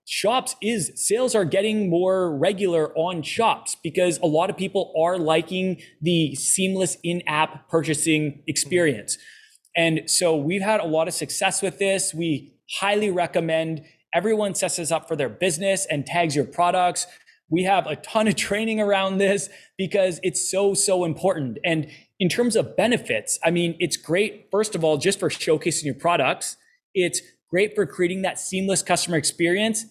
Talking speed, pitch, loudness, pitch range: 165 wpm, 180 Hz, -22 LUFS, 160-195 Hz